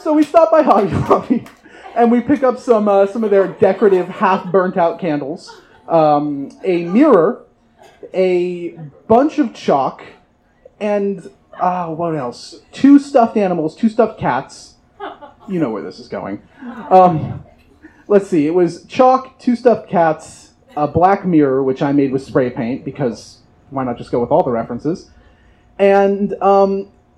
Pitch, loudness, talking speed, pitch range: 190 Hz, -15 LUFS, 155 wpm, 160-235 Hz